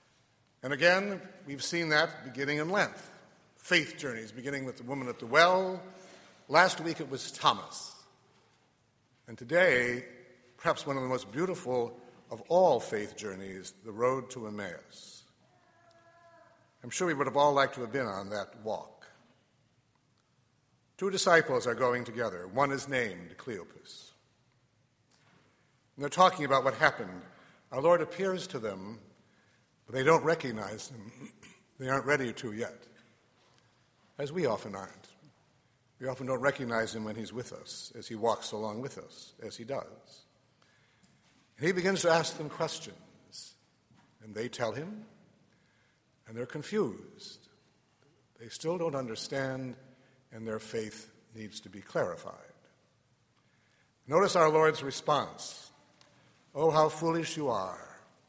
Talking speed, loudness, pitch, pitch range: 140 wpm, -31 LUFS, 135 Hz, 120-165 Hz